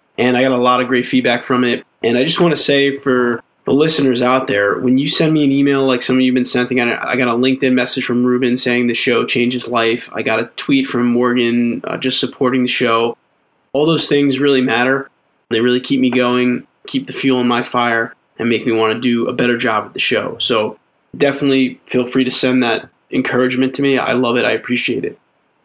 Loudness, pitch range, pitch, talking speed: -15 LUFS, 120-135 Hz, 125 Hz, 235 wpm